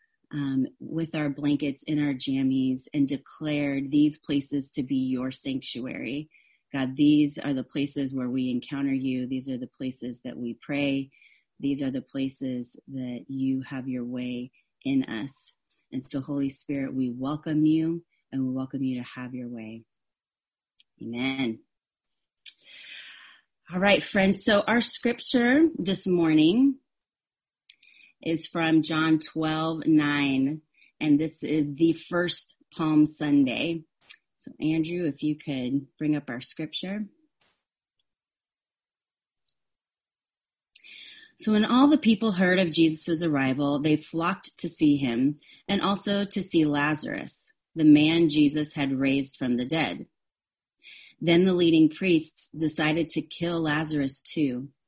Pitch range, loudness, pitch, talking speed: 135-165 Hz, -26 LUFS, 150 Hz, 135 wpm